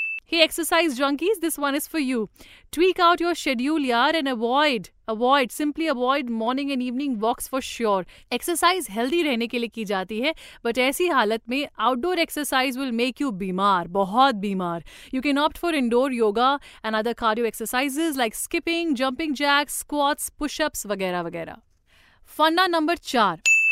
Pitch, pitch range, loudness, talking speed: 270 Hz, 235-315 Hz, -23 LUFS, 140 wpm